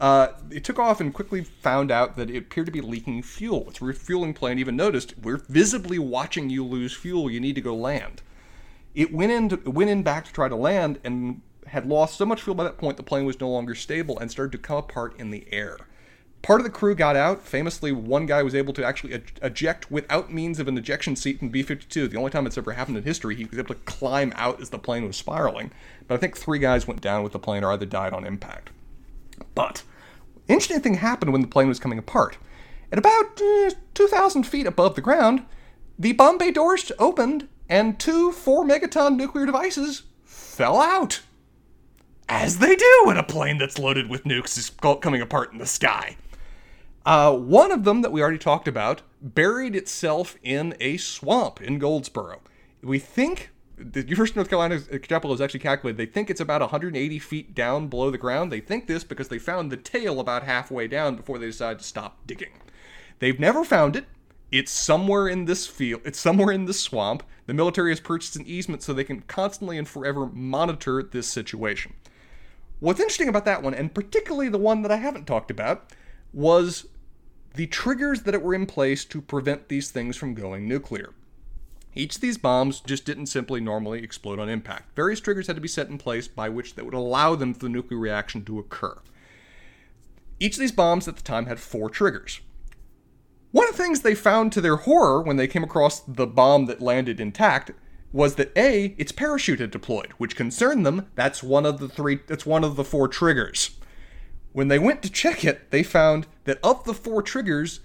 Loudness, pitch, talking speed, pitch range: -23 LUFS, 145 Hz, 205 wpm, 130-195 Hz